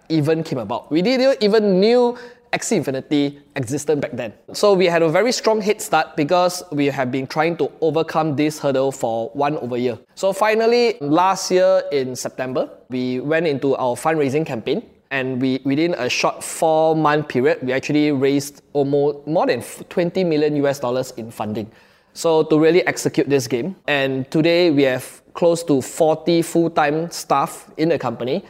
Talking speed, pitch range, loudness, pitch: 175 wpm, 135-170 Hz, -19 LUFS, 150 Hz